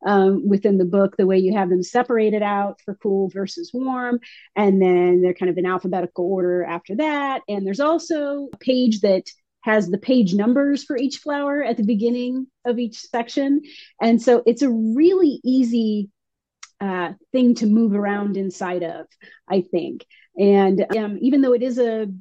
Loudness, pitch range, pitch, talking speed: -20 LUFS, 195-255 Hz, 215 Hz, 180 wpm